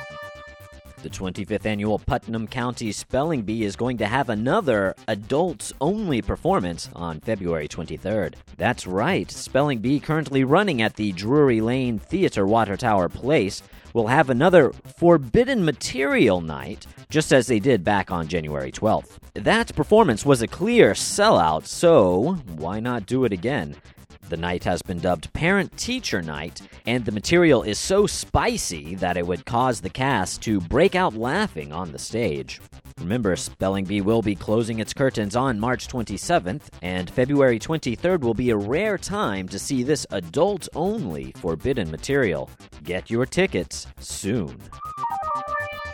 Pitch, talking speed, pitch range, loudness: 110 Hz, 150 wpm, 90-145 Hz, -22 LUFS